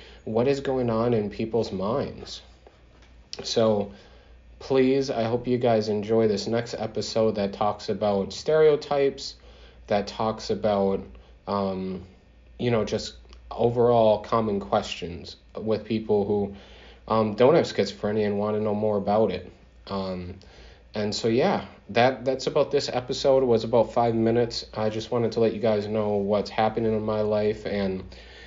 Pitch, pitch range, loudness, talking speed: 105 Hz, 95-115 Hz, -25 LUFS, 155 wpm